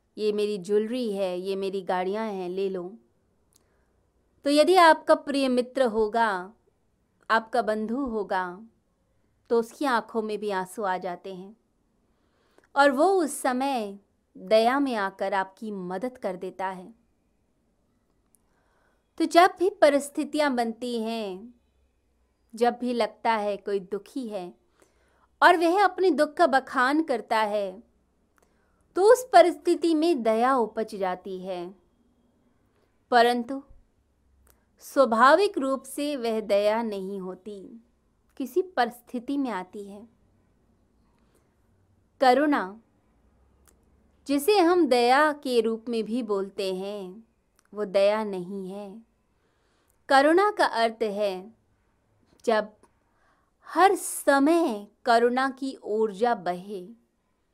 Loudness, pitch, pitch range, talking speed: -25 LUFS, 225 Hz, 195-270 Hz, 110 wpm